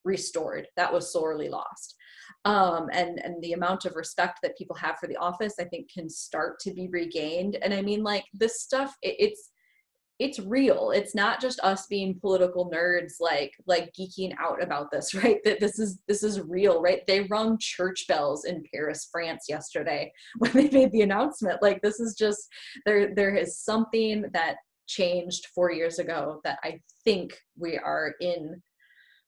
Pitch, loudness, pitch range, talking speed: 200 Hz, -27 LUFS, 180-225 Hz, 180 wpm